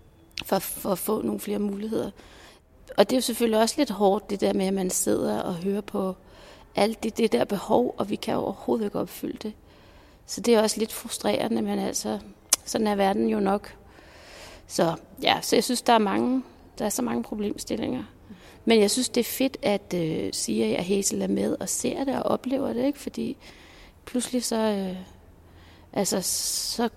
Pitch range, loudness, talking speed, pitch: 195-235 Hz, -26 LUFS, 200 wpm, 215 Hz